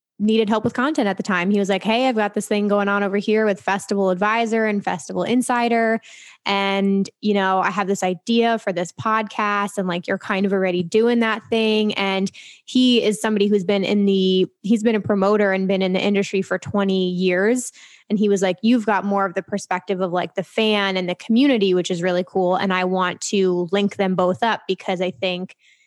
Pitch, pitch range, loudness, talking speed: 200 Hz, 190-220 Hz, -20 LUFS, 225 wpm